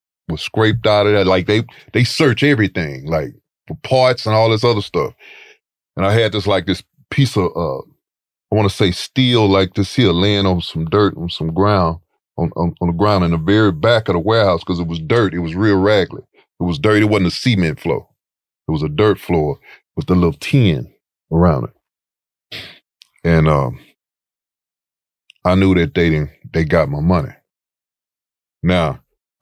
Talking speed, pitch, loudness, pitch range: 190 wpm, 95 Hz, -16 LUFS, 85-105 Hz